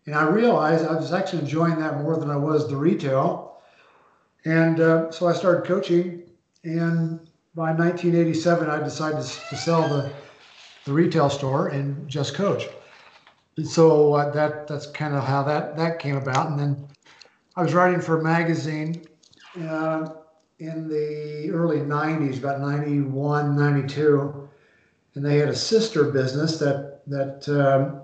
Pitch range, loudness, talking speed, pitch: 145-165 Hz, -23 LUFS, 150 wpm, 155 Hz